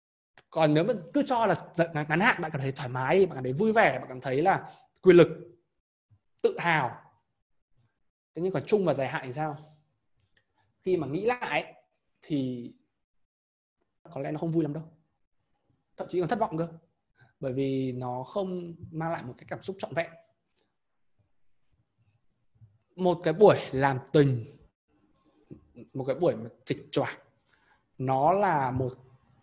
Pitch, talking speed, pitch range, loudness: 155 Hz, 160 wpm, 130-175 Hz, -28 LUFS